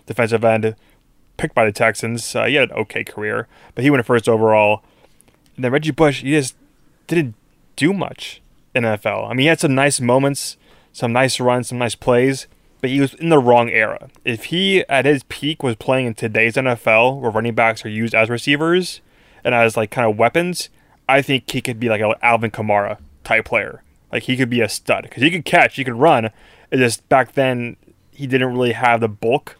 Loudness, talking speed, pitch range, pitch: -17 LUFS, 215 wpm, 115-140 Hz, 125 Hz